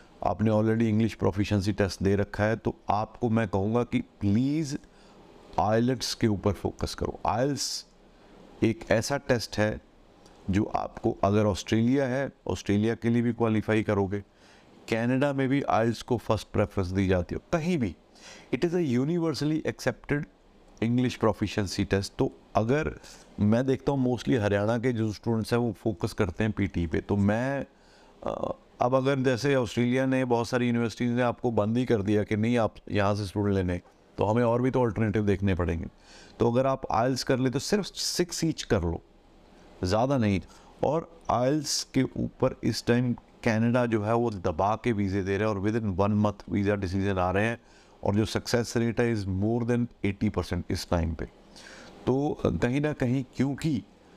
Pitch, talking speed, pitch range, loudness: 110 Hz, 180 wpm, 100-125 Hz, -28 LUFS